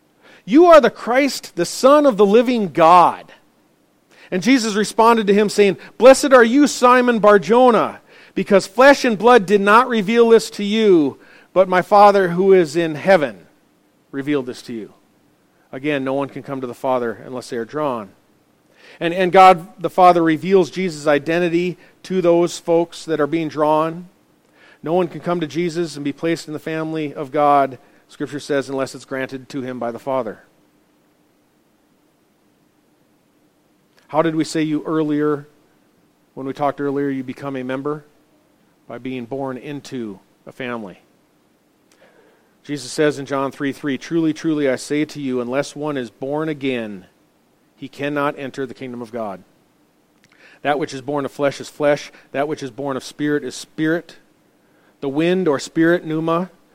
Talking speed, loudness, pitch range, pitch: 170 wpm, -17 LUFS, 135-185 Hz, 155 Hz